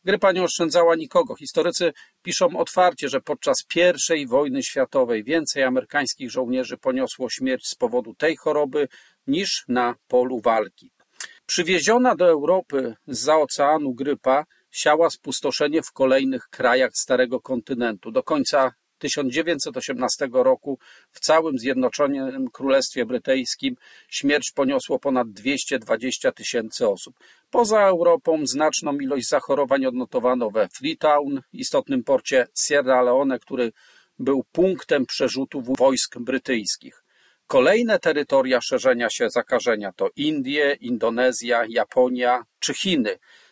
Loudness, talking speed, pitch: -21 LUFS, 115 wpm, 150 Hz